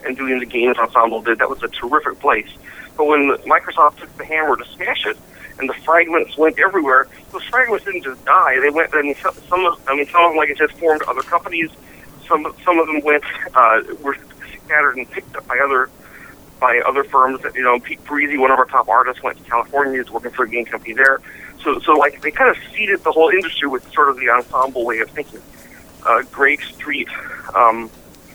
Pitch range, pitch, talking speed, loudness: 125-160 Hz, 140 Hz, 225 wpm, -16 LUFS